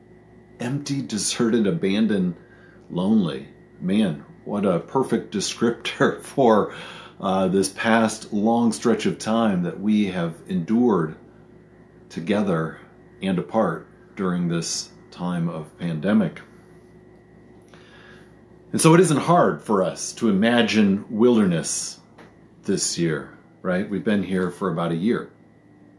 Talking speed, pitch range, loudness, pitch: 115 wpm, 95-140 Hz, -22 LUFS, 110 Hz